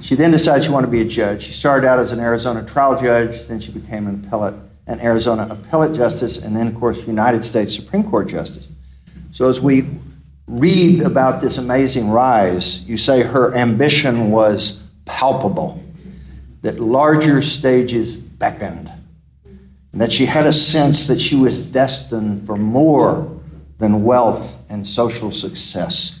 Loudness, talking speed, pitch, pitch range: -15 LUFS, 160 wpm, 115 Hz, 105-135 Hz